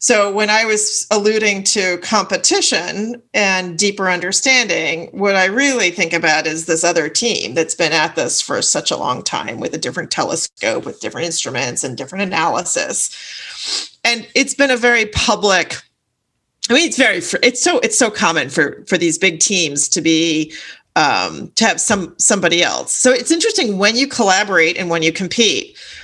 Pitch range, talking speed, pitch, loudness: 170-235 Hz, 175 wpm, 200 Hz, -15 LUFS